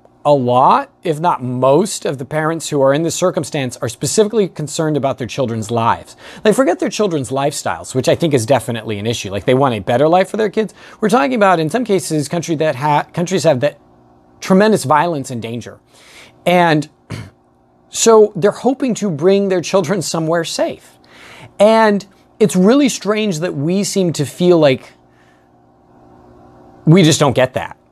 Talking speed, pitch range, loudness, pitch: 180 wpm, 120-190 Hz, -15 LUFS, 150 Hz